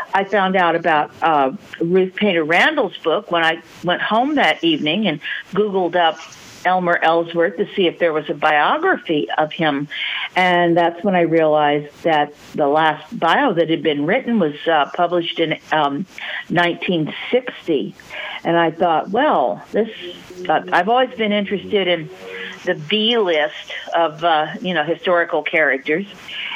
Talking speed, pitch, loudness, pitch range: 150 wpm, 170 Hz, -18 LUFS, 160-190 Hz